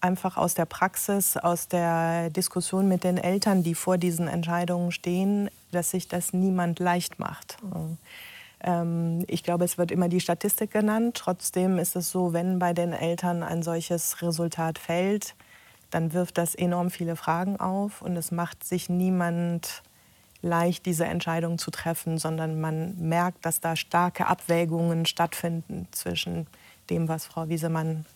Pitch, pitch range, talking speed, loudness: 175 Hz, 170-180 Hz, 150 wpm, -27 LUFS